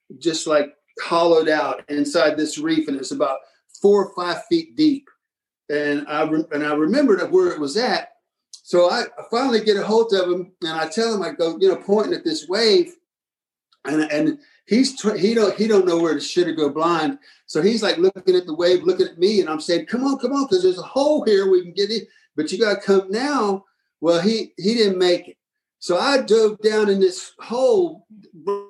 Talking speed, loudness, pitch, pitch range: 220 wpm, -20 LUFS, 200 Hz, 170-270 Hz